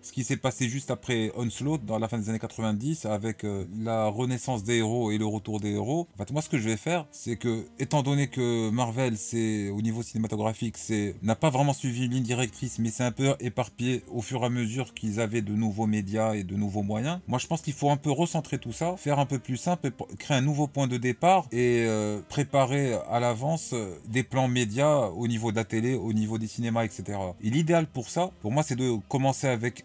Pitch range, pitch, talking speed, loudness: 110-135 Hz, 120 Hz, 235 wpm, -28 LUFS